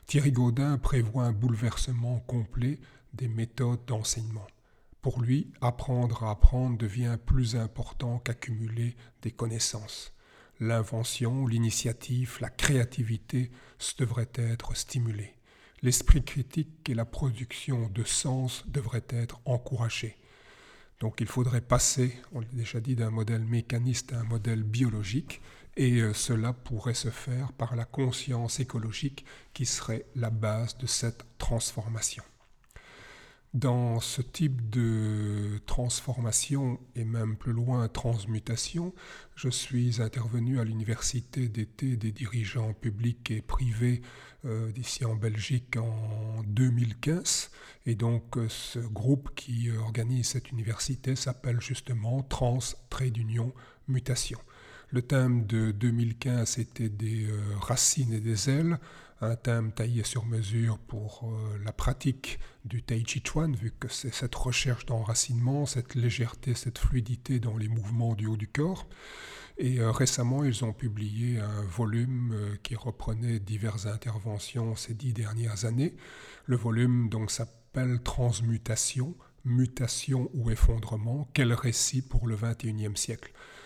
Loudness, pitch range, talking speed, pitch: -30 LUFS, 115-125 Hz, 125 wpm, 120 Hz